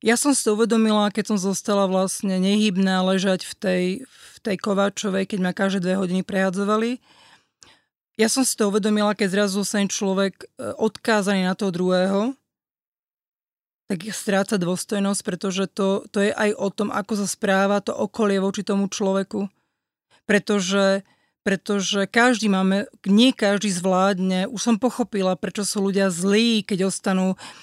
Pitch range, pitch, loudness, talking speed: 195-215 Hz, 200 Hz, -22 LUFS, 155 wpm